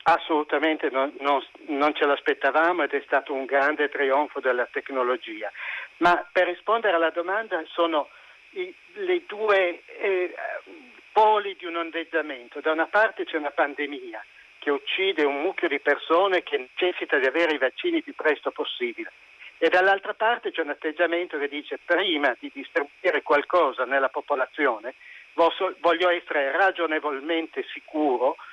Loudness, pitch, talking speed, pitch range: -24 LUFS, 170 Hz, 140 wpm, 145-200 Hz